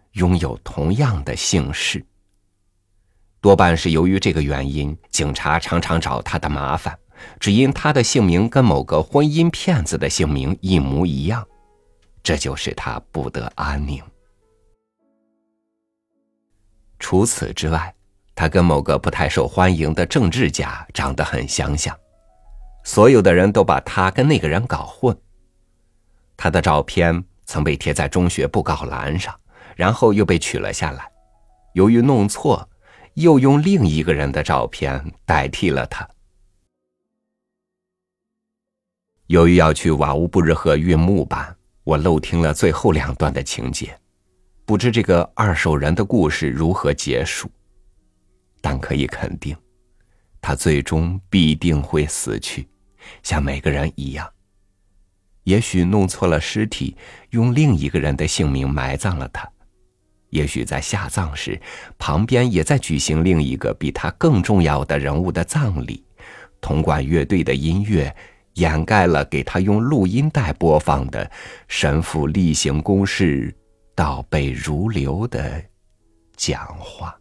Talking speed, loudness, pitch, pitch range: 200 characters per minute, -18 LUFS, 90 Hz, 75-100 Hz